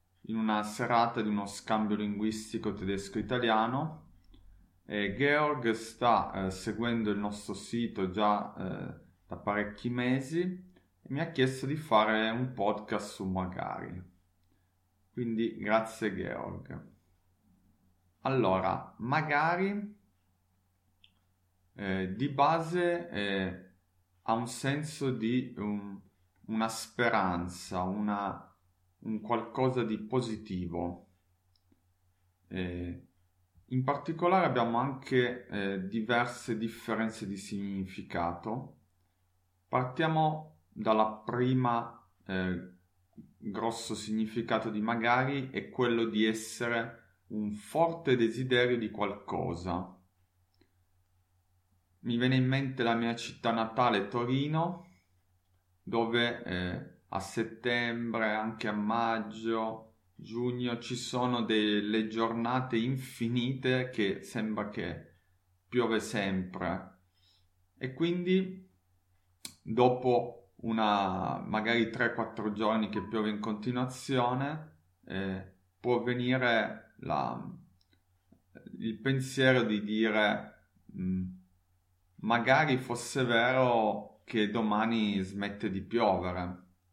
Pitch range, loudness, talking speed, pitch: 95-120 Hz, -32 LUFS, 90 wpm, 110 Hz